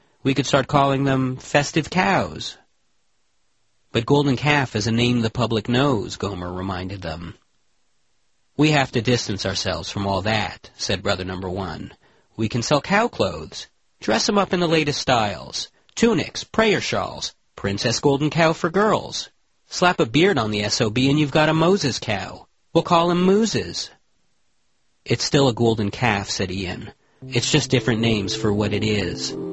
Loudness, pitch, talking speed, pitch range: -21 LUFS, 120 Hz, 170 wpm, 105-150 Hz